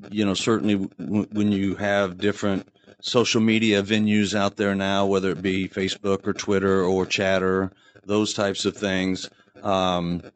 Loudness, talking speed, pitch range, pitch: -23 LUFS, 155 wpm, 95-105 Hz, 100 Hz